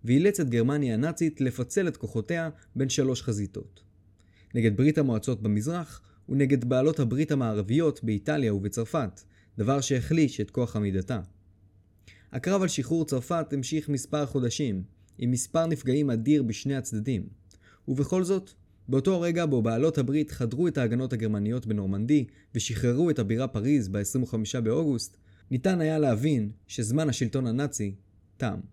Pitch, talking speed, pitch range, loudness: 125 Hz, 130 wpm, 105-145 Hz, -28 LUFS